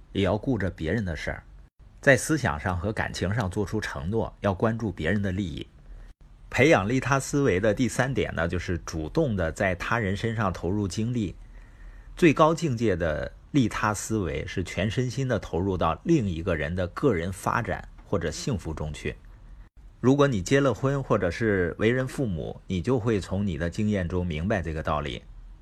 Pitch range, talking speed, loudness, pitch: 90-120 Hz, 265 characters per minute, -26 LUFS, 105 Hz